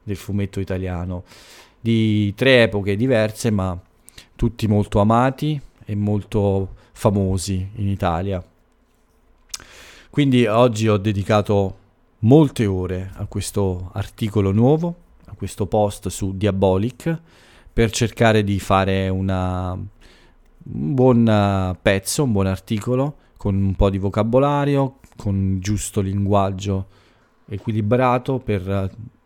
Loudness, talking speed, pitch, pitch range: -20 LUFS, 105 wpm, 105 Hz, 95-115 Hz